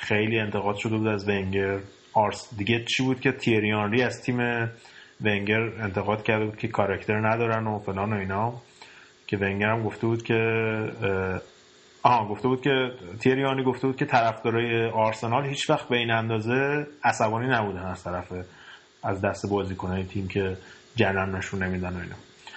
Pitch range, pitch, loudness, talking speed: 100-115 Hz, 110 Hz, -26 LUFS, 160 wpm